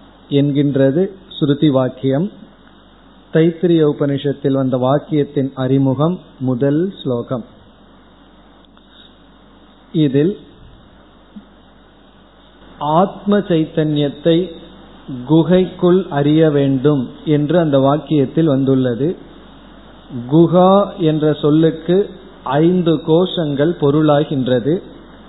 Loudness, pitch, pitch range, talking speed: -15 LUFS, 150 Hz, 140-175 Hz, 60 wpm